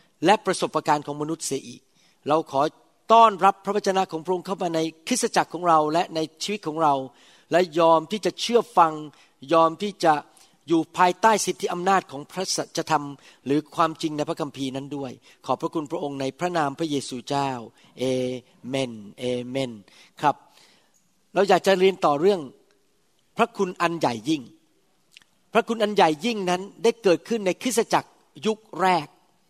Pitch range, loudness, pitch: 145-190 Hz, -23 LUFS, 165 Hz